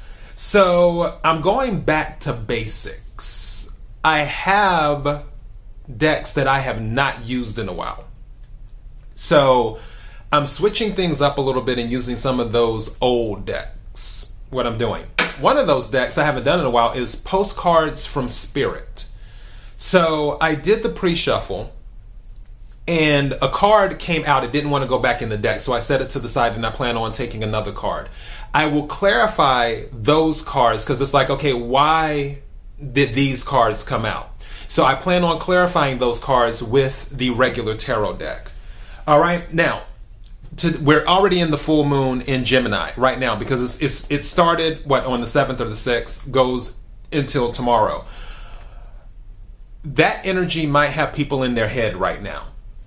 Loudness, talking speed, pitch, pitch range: -19 LUFS, 170 wpm, 135 Hz, 115-155 Hz